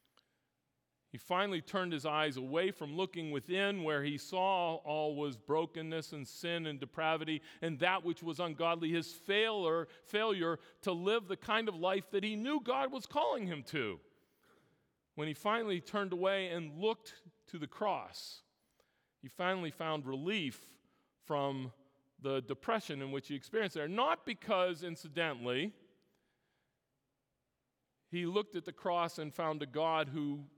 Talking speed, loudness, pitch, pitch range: 150 wpm, -37 LUFS, 165 Hz, 150-190 Hz